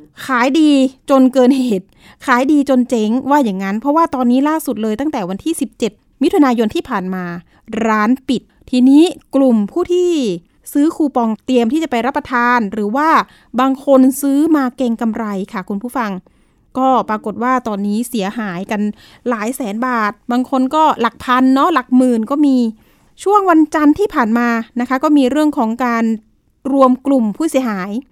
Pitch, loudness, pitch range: 255 Hz, -15 LUFS, 225-280 Hz